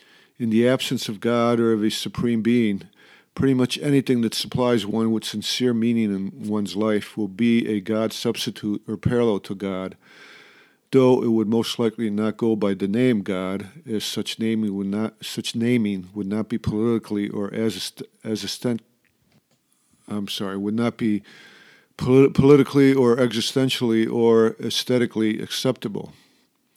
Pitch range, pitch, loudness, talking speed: 105-120 Hz, 115 Hz, -22 LUFS, 155 wpm